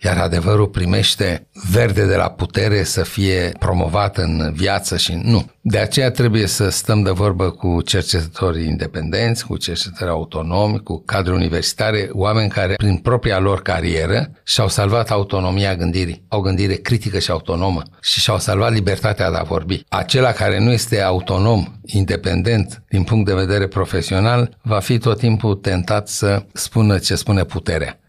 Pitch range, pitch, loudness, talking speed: 90-110 Hz, 100 Hz, -17 LUFS, 155 wpm